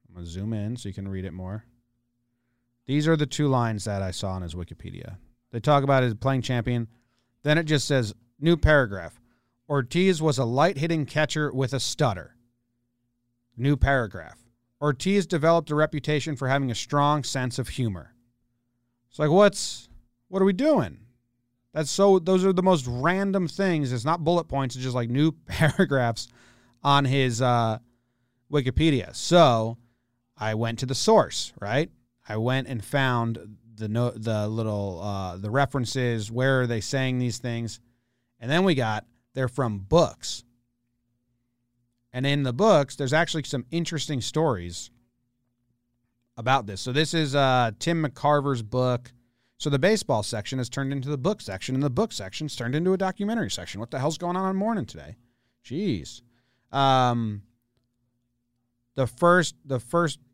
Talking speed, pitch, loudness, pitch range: 165 wpm, 125 Hz, -25 LUFS, 120-145 Hz